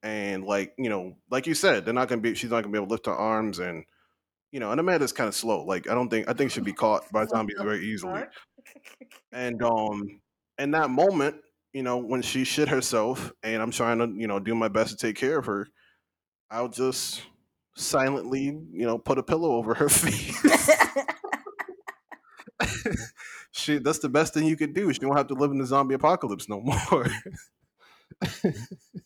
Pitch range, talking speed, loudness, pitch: 110-150 Hz, 200 wpm, -26 LUFS, 130 Hz